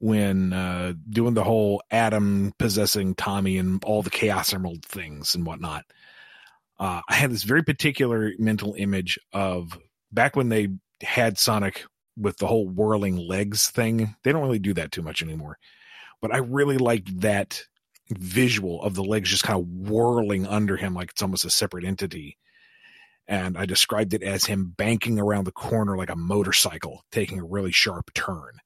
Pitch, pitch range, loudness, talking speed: 100 Hz, 95-110 Hz, -24 LUFS, 175 wpm